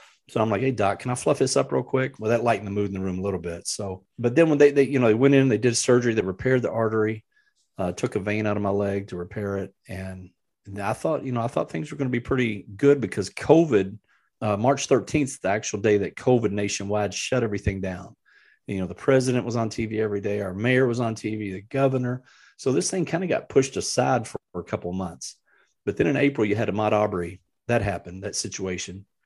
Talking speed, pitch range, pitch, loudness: 250 wpm, 100-125 Hz, 105 Hz, -24 LUFS